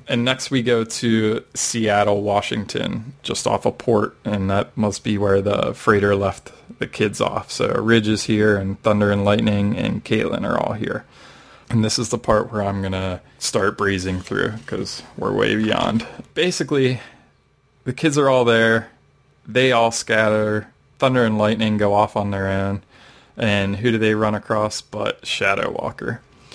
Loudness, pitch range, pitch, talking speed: -20 LUFS, 100-120 Hz, 110 Hz, 175 wpm